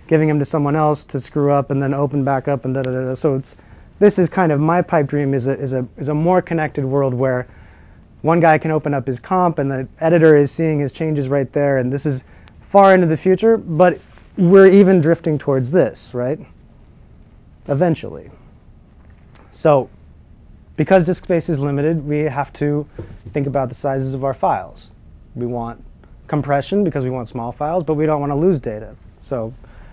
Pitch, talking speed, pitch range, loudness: 145 Hz, 195 wpm, 130-160 Hz, -17 LUFS